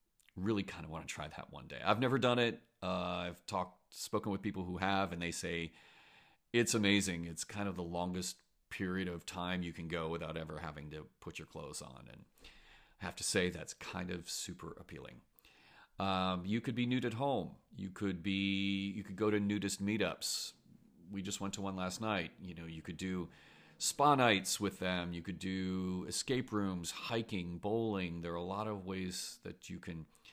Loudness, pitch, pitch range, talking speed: -38 LUFS, 95 Hz, 90-105 Hz, 205 wpm